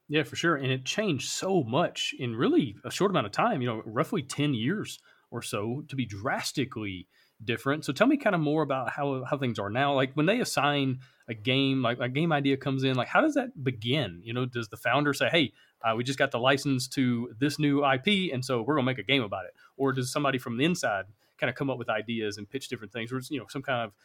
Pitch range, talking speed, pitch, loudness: 120-145 Hz, 260 wpm, 135 Hz, -28 LUFS